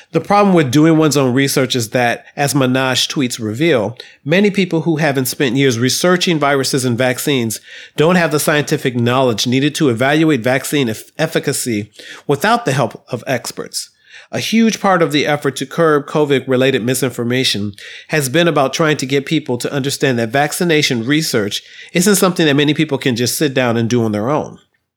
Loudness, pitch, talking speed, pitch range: -15 LUFS, 145 Hz, 180 wpm, 130-160 Hz